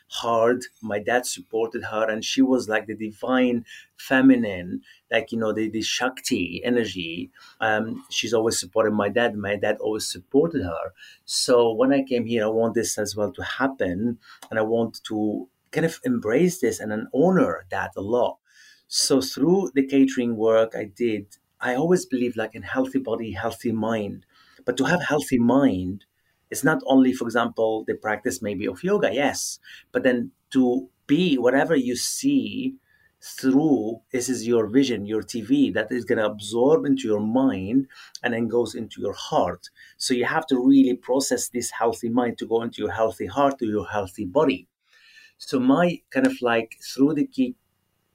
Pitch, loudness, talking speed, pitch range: 120 Hz, -23 LUFS, 180 wpm, 110-135 Hz